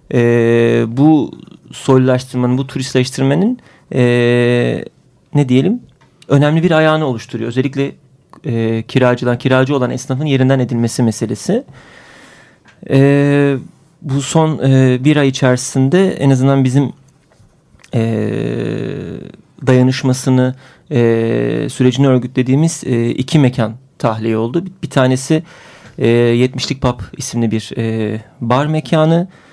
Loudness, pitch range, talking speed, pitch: -14 LUFS, 120-140 Hz, 105 wpm, 130 Hz